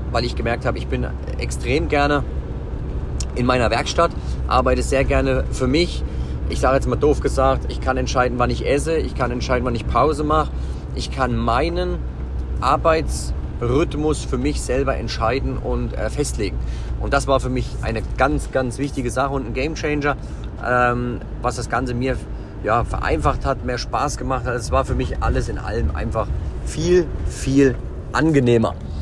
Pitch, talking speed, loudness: 115 Hz, 170 wpm, -21 LUFS